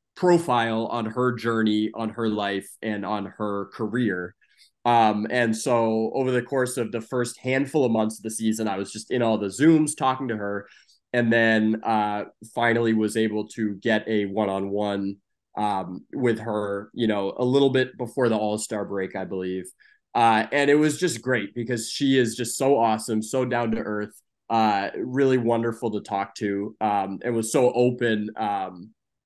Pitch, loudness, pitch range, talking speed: 110 Hz, -24 LUFS, 105-125 Hz, 180 wpm